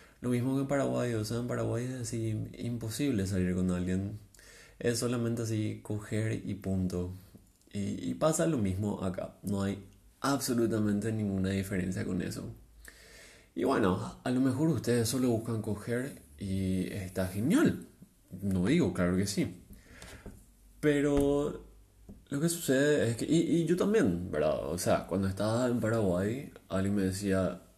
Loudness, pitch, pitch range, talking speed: -31 LUFS, 105 Hz, 95-125 Hz, 155 wpm